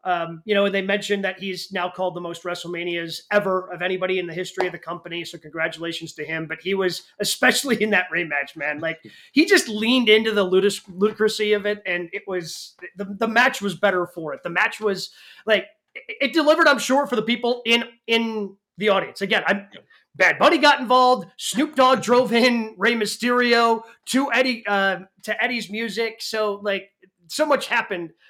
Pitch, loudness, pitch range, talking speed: 205 Hz, -21 LUFS, 180-235 Hz, 200 wpm